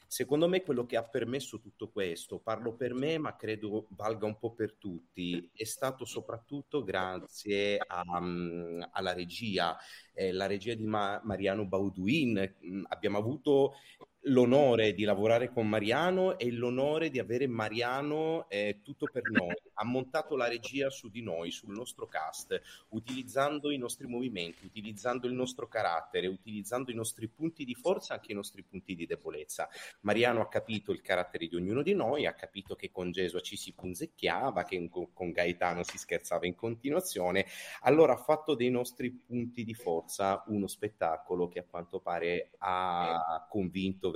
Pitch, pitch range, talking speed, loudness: 110 Hz, 95-125 Hz, 160 wpm, -33 LUFS